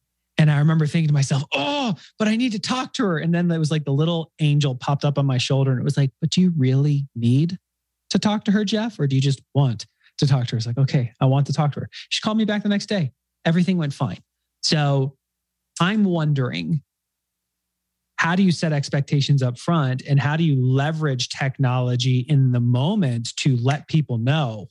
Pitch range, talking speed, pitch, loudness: 130-165 Hz, 225 wpm, 145 Hz, -21 LUFS